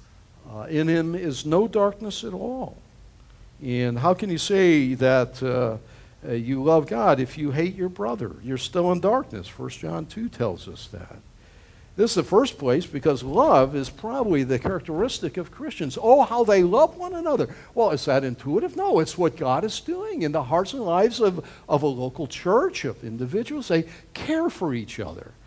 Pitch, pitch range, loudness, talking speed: 165 Hz, 130-210 Hz, -23 LUFS, 190 wpm